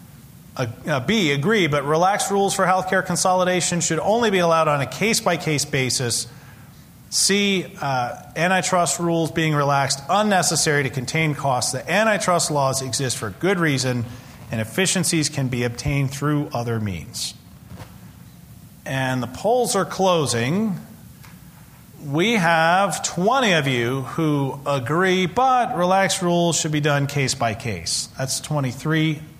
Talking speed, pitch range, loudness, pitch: 135 wpm, 135-185 Hz, -20 LUFS, 155 Hz